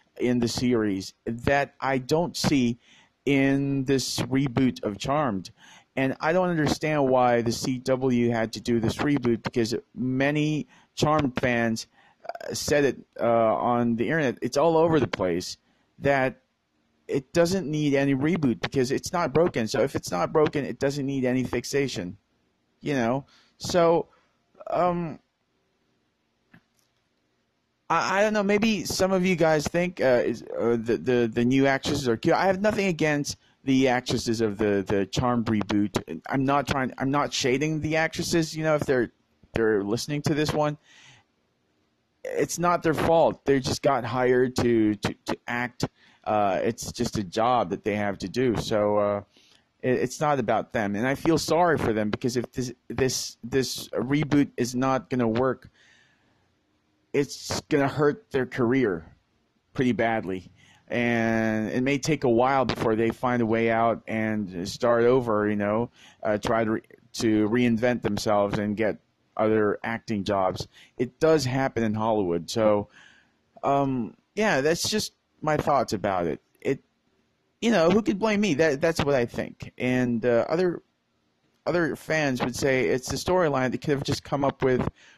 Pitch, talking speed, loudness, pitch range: 125 Hz, 165 wpm, -25 LUFS, 115-145 Hz